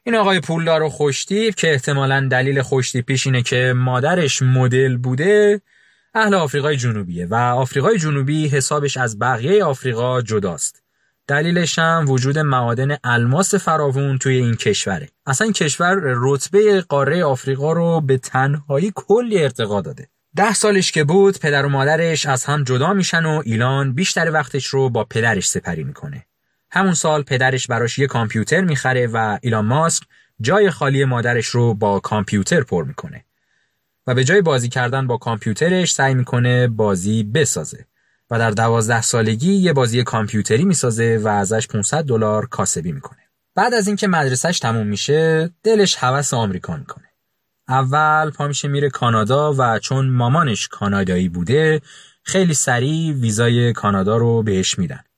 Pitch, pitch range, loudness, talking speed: 135 Hz, 120-160 Hz, -17 LUFS, 150 wpm